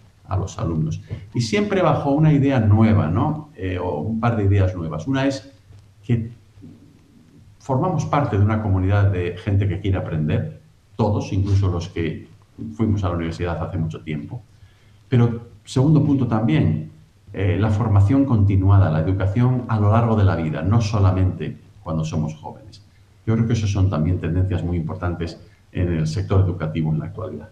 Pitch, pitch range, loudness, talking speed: 100 Hz, 85-110 Hz, -21 LUFS, 170 wpm